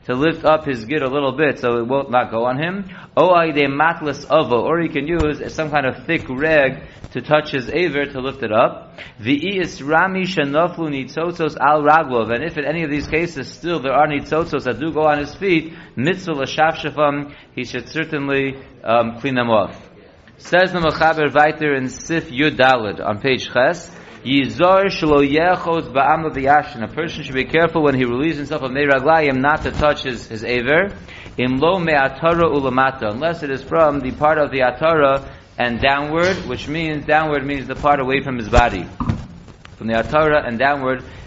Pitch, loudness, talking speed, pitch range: 145 Hz, -18 LUFS, 200 wpm, 130-155 Hz